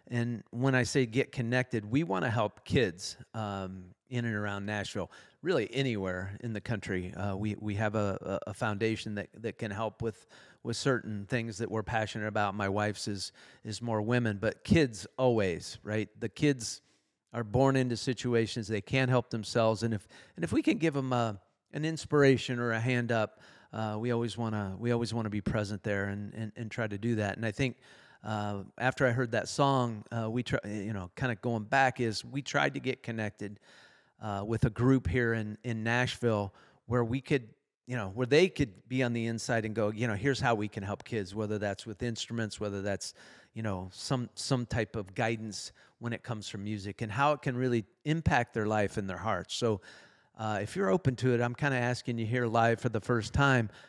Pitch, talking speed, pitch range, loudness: 115 Hz, 215 wpm, 105-125 Hz, -32 LUFS